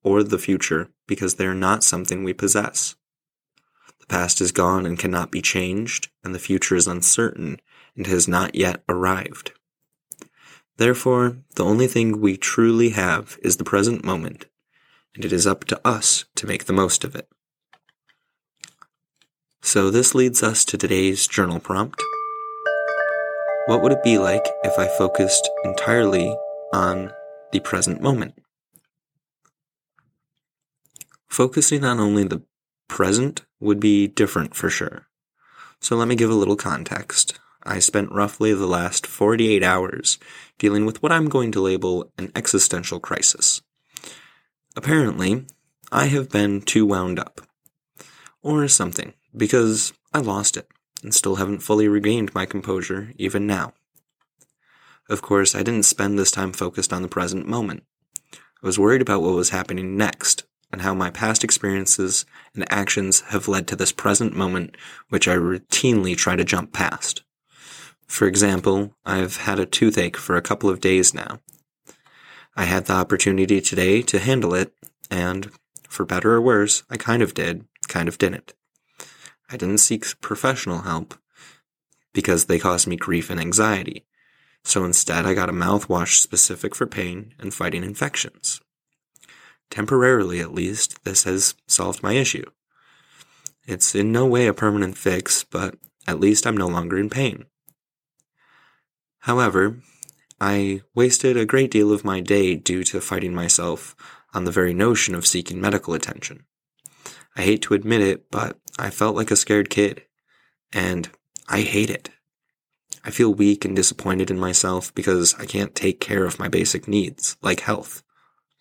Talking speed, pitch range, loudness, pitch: 150 wpm, 90-110 Hz, -20 LUFS, 100 Hz